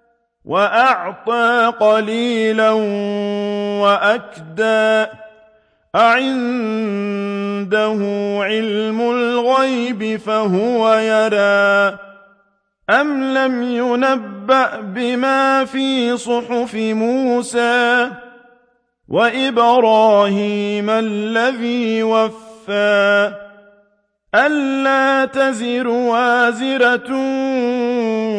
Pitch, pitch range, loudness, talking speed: 225 Hz, 205-245 Hz, -16 LUFS, 45 wpm